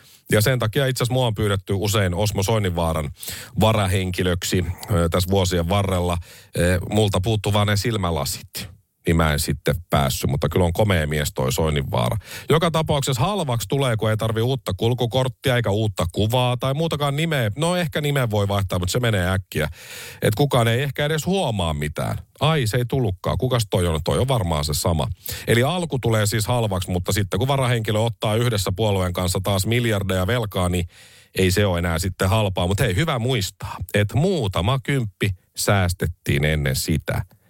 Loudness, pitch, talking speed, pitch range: -21 LUFS, 105 Hz, 170 wpm, 95-125 Hz